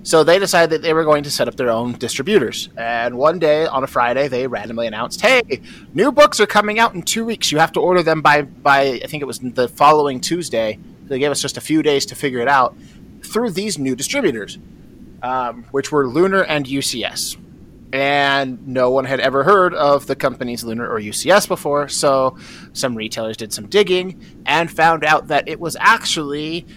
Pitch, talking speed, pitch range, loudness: 145 Hz, 210 wpm, 130-165 Hz, -17 LUFS